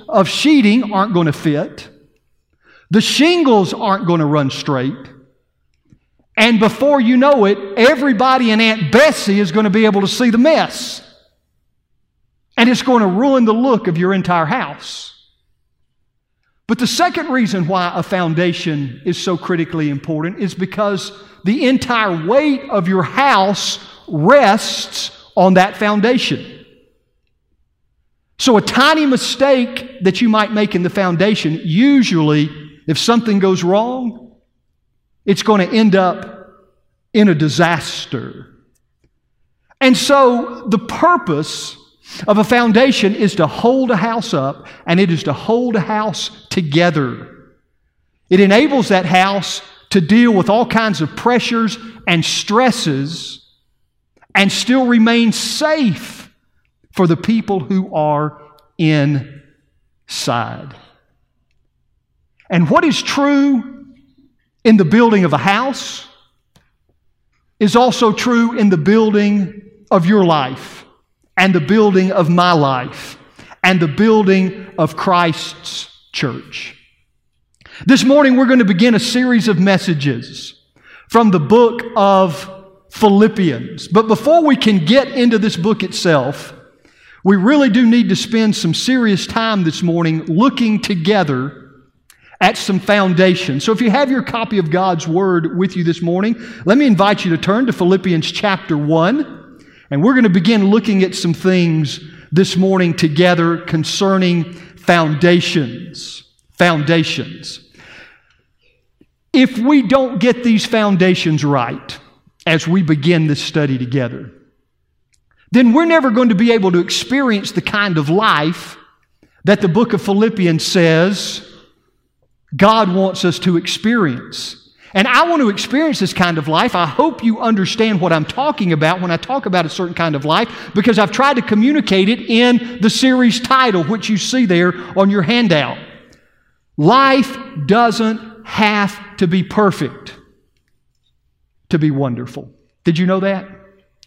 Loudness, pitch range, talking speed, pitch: -14 LUFS, 170-230 Hz, 140 wpm, 195 Hz